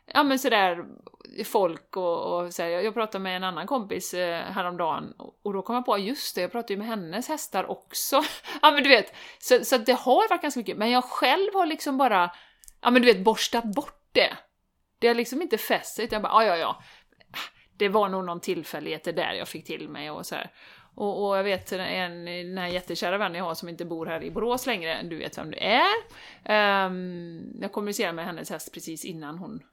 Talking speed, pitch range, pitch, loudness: 215 wpm, 180-255 Hz, 205 Hz, -26 LUFS